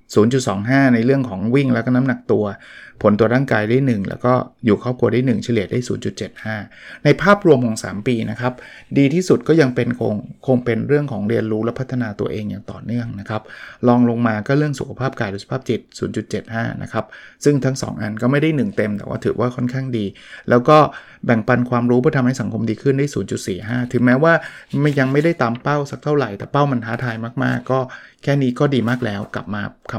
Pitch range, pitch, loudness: 110-135 Hz, 125 Hz, -18 LUFS